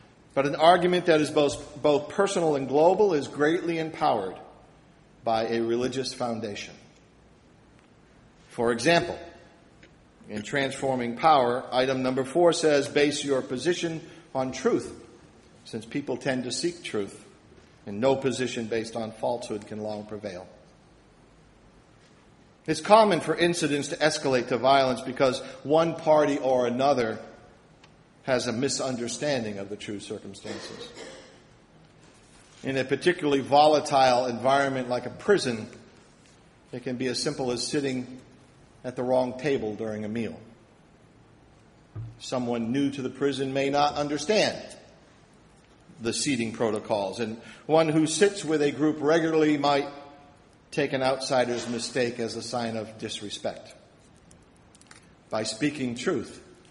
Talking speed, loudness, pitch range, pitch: 125 wpm, -26 LUFS, 120-150 Hz, 135 Hz